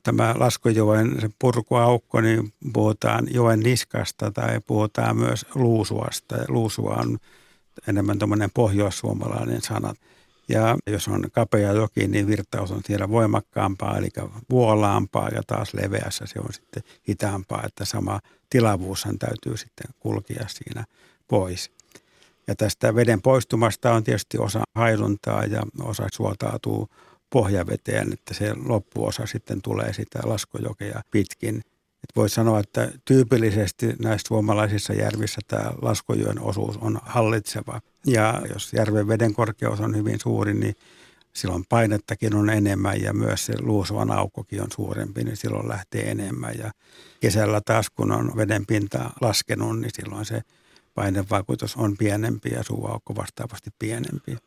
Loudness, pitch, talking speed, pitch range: -24 LUFS, 110 Hz, 130 wpm, 105-115 Hz